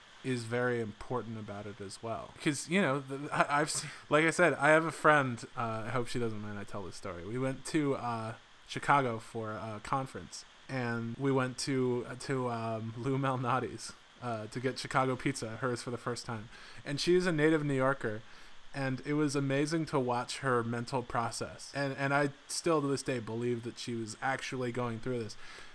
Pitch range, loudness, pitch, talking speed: 115-140 Hz, -33 LUFS, 125 Hz, 200 wpm